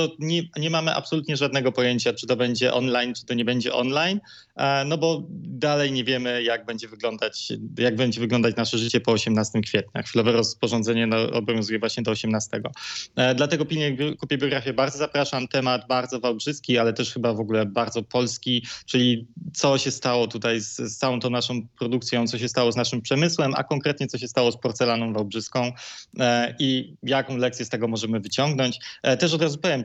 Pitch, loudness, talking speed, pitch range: 125 Hz, -24 LUFS, 185 wpm, 115-140 Hz